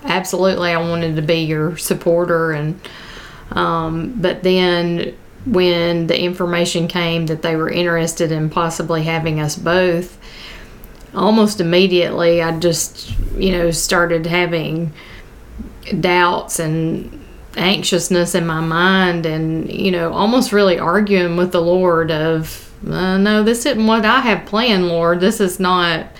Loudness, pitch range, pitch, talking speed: -16 LUFS, 165-185 Hz, 175 Hz, 135 wpm